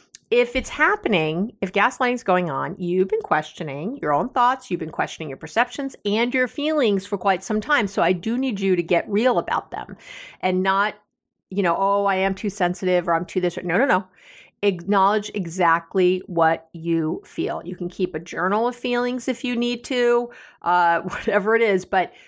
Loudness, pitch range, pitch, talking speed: -22 LUFS, 180-240 Hz, 195 Hz, 200 wpm